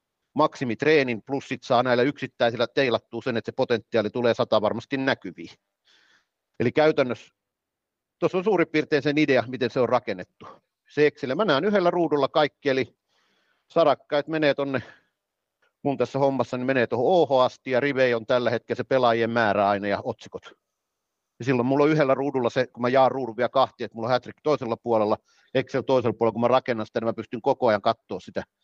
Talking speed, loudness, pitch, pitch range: 190 wpm, -24 LUFS, 125 Hz, 115-140 Hz